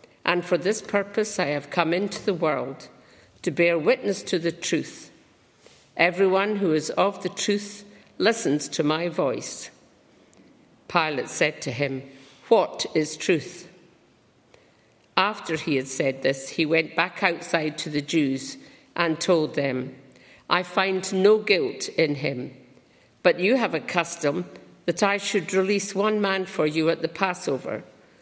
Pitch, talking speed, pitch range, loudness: 175 Hz, 150 wpm, 155-195 Hz, -24 LUFS